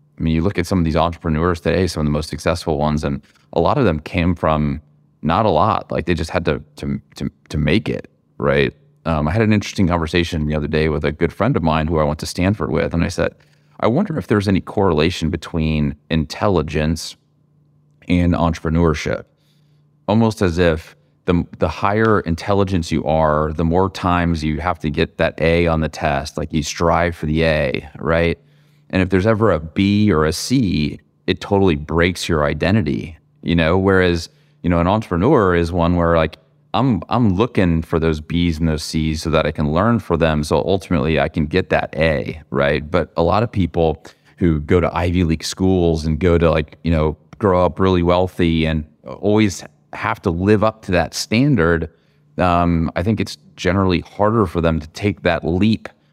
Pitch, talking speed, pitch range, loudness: 85 Hz, 205 wpm, 80-95 Hz, -18 LUFS